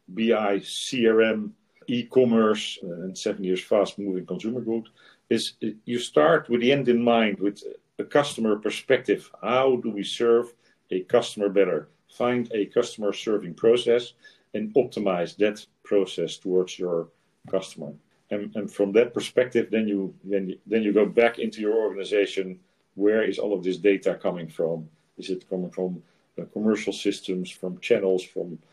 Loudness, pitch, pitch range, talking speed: -25 LUFS, 110 Hz, 95-120 Hz, 150 wpm